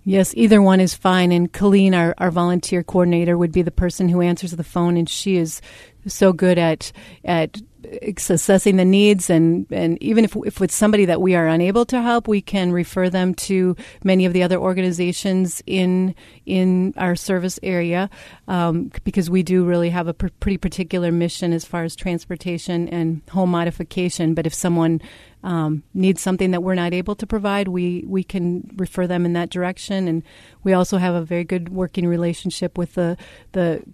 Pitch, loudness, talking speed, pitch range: 180 Hz, -19 LUFS, 190 wpm, 175-190 Hz